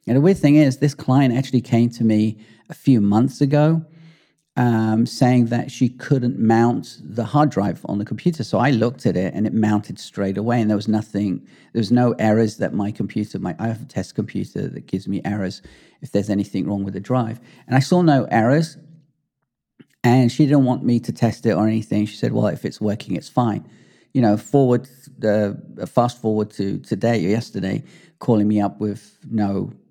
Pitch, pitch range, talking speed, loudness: 115 Hz, 105-130 Hz, 205 wpm, -20 LUFS